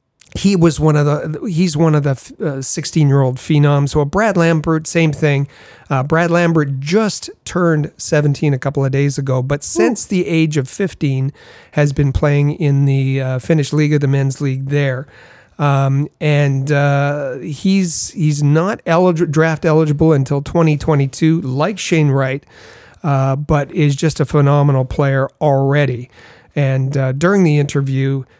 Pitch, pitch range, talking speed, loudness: 145 Hz, 140-160 Hz, 165 wpm, -15 LUFS